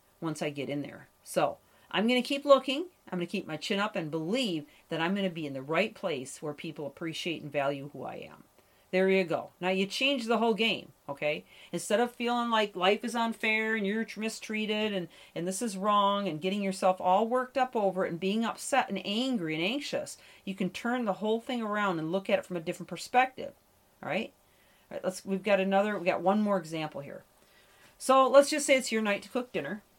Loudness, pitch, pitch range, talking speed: -30 LUFS, 195 Hz, 175-230 Hz, 230 wpm